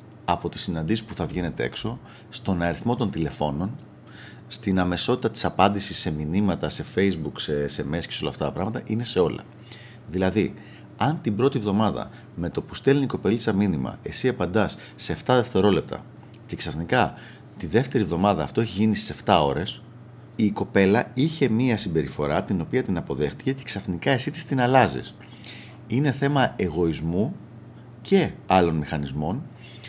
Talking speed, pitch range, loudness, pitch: 160 wpm, 85-120 Hz, -24 LUFS, 100 Hz